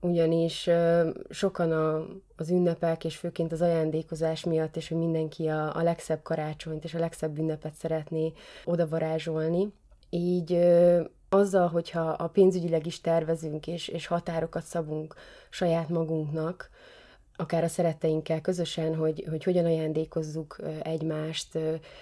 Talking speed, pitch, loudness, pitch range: 115 wpm, 165 Hz, -28 LUFS, 160-170 Hz